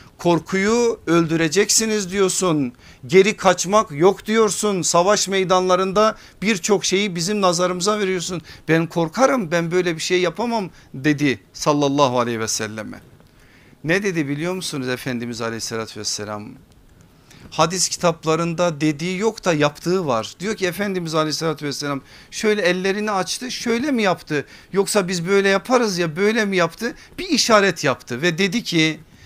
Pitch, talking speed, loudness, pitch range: 180 Hz, 135 wpm, -19 LUFS, 150-200 Hz